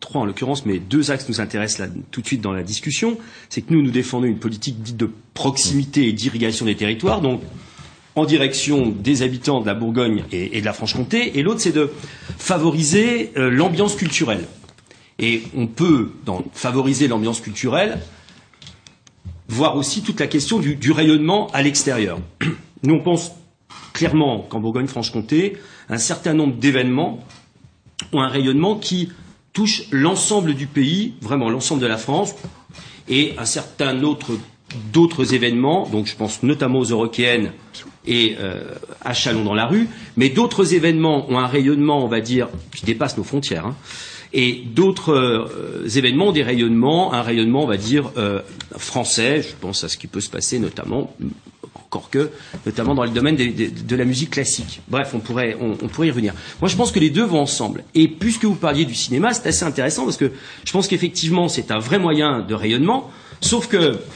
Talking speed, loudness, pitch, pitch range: 180 wpm, -19 LUFS, 135 Hz, 115-160 Hz